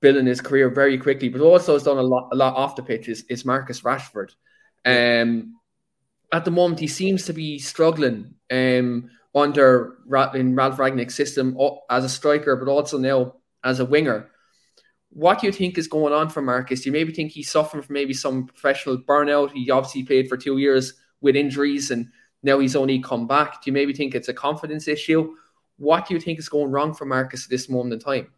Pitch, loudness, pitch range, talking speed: 140 Hz, -21 LUFS, 130-150 Hz, 210 wpm